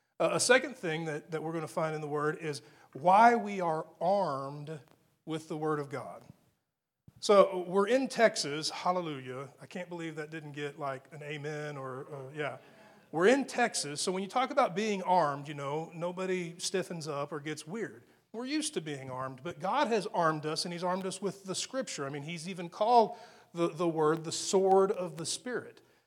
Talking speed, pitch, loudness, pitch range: 205 wpm, 170 Hz, -31 LUFS, 150-195 Hz